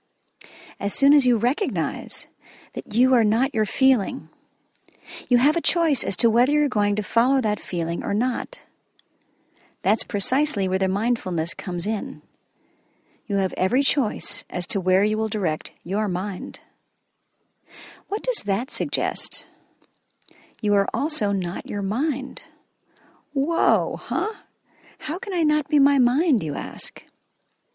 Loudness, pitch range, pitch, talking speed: -22 LUFS, 200-295 Hz, 245 Hz, 145 wpm